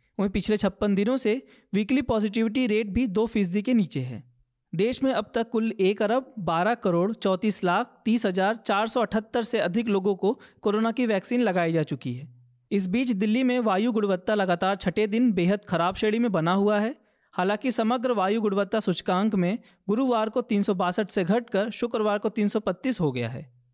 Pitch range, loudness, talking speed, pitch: 190-230 Hz, -25 LUFS, 185 wpm, 210 Hz